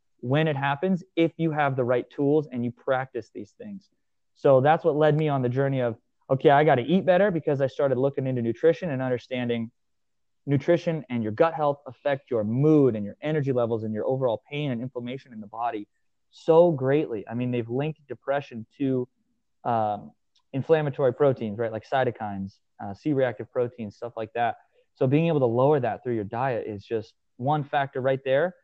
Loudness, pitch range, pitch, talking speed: -25 LUFS, 120-150 Hz, 130 Hz, 195 wpm